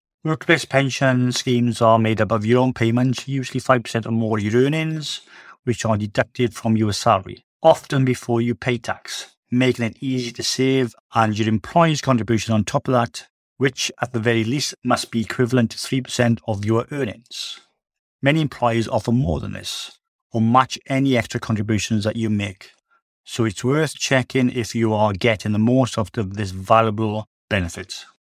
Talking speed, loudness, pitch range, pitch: 180 wpm, -20 LUFS, 110-130 Hz, 120 Hz